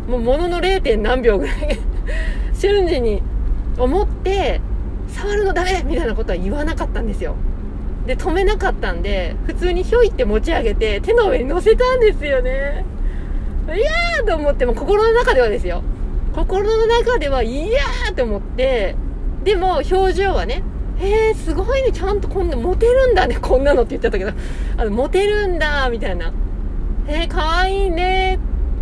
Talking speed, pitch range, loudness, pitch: 325 characters per minute, 340-445 Hz, -18 LUFS, 380 Hz